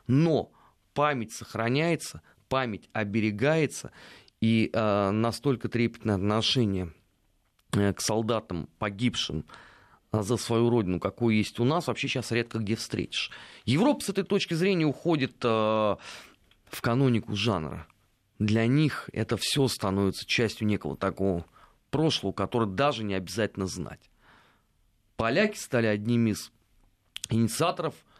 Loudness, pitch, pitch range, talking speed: -28 LUFS, 115 Hz, 100-125 Hz, 115 wpm